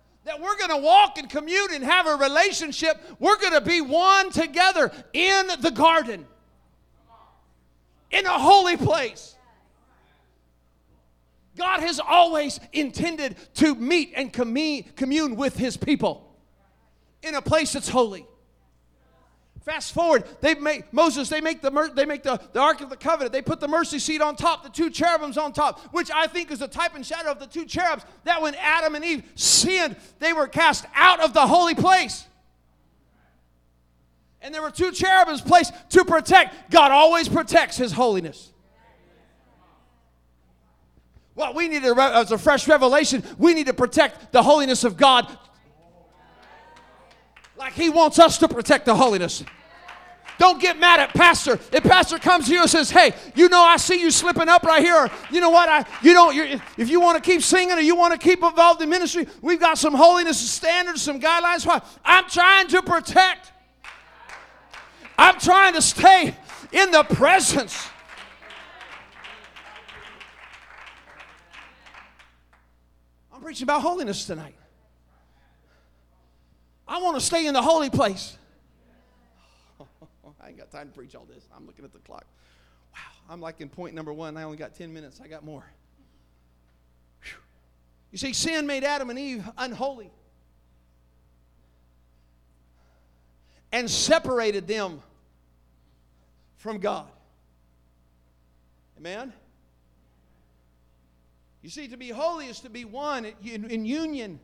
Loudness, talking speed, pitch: -19 LUFS, 150 wpm, 275 Hz